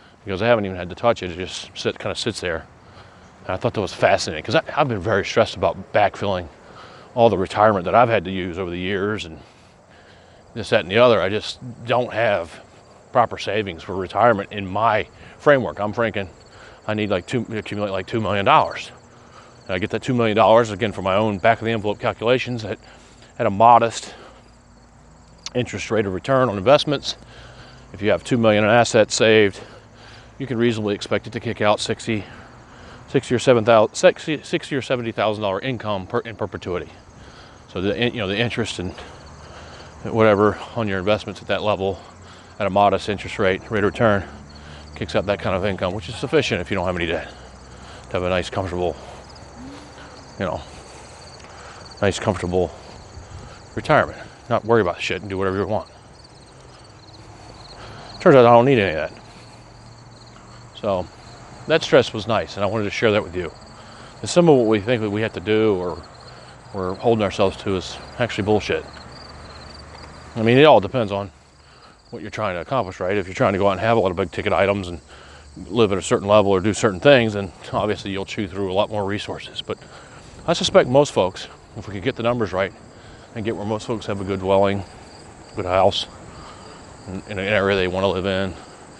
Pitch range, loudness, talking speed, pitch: 95-115 Hz, -20 LUFS, 200 wpm, 105 Hz